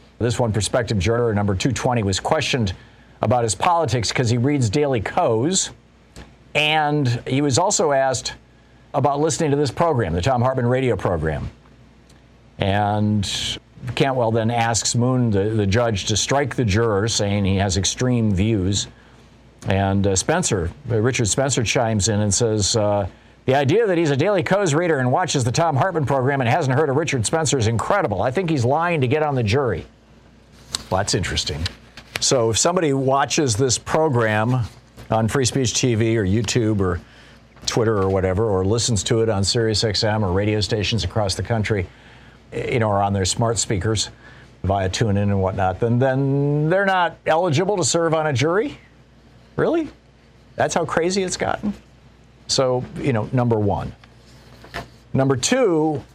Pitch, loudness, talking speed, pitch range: 120 Hz, -20 LUFS, 165 wpm, 105-140 Hz